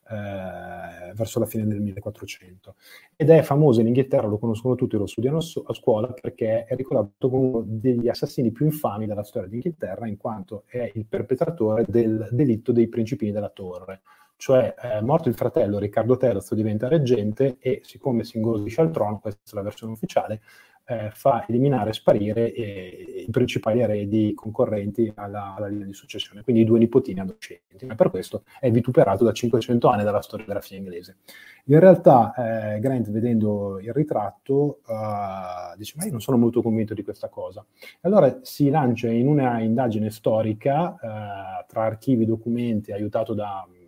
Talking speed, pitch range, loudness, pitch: 175 wpm, 105-125 Hz, -23 LUFS, 115 Hz